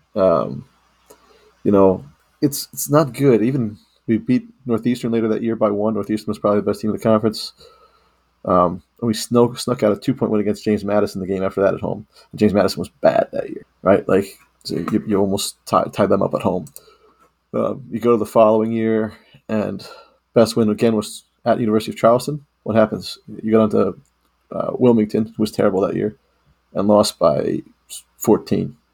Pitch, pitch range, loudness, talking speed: 110 Hz, 105-120 Hz, -19 LUFS, 195 wpm